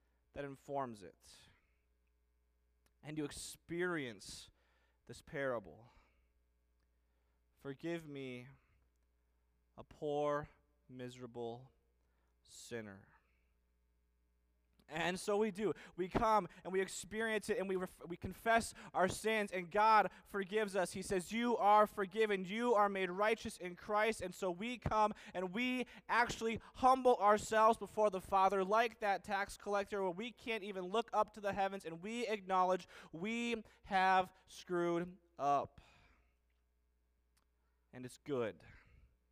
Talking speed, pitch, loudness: 125 wpm, 180 Hz, -37 LUFS